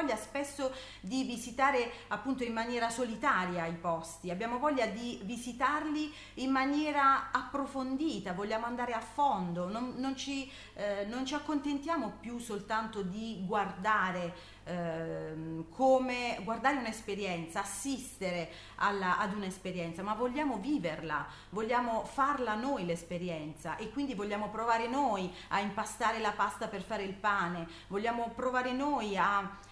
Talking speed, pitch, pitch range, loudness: 125 wpm, 225 Hz, 195-260 Hz, -34 LUFS